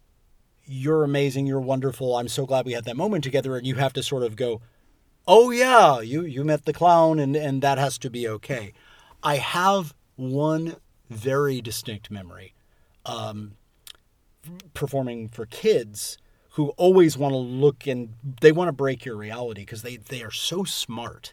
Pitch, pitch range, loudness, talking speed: 135 Hz, 115-150 Hz, -23 LUFS, 170 wpm